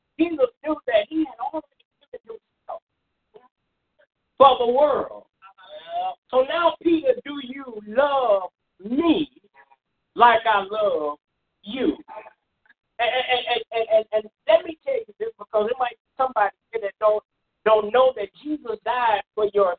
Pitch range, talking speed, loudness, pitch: 215-315 Hz, 140 wpm, -22 LUFS, 255 Hz